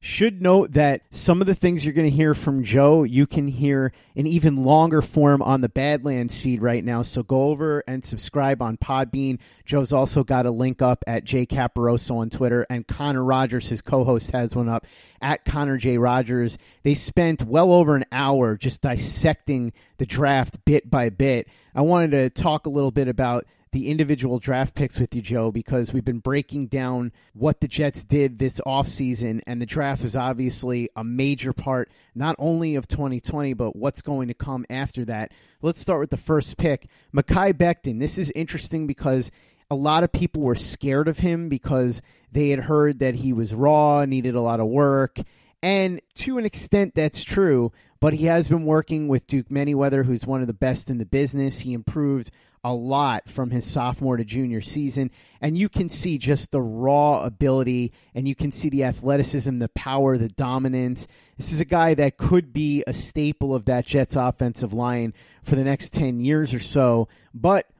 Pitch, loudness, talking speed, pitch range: 135 Hz, -22 LUFS, 195 wpm, 125-145 Hz